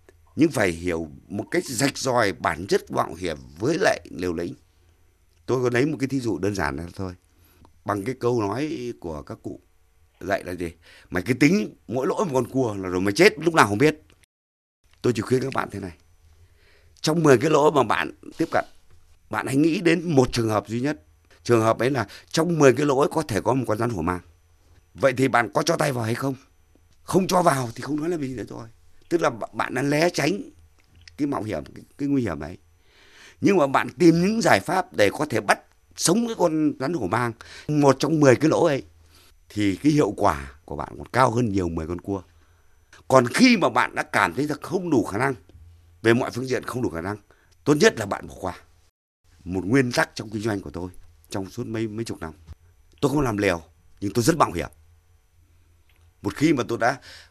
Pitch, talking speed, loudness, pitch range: 100 Hz, 225 wpm, -23 LUFS, 85-130 Hz